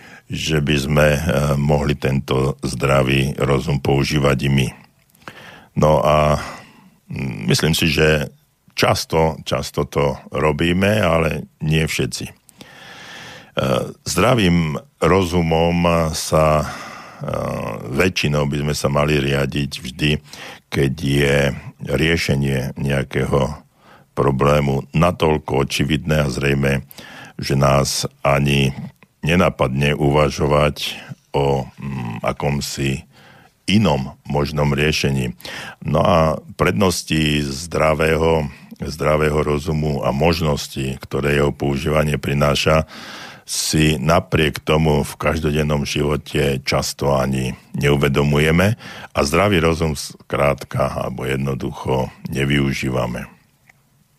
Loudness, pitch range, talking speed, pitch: -18 LUFS, 70-75 Hz, 90 wpm, 75 Hz